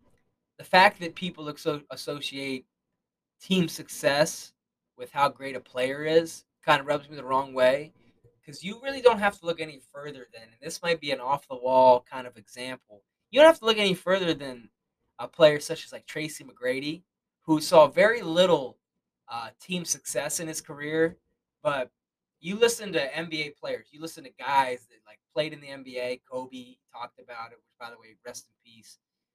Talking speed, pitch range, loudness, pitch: 185 wpm, 130-170 Hz, -26 LUFS, 150 Hz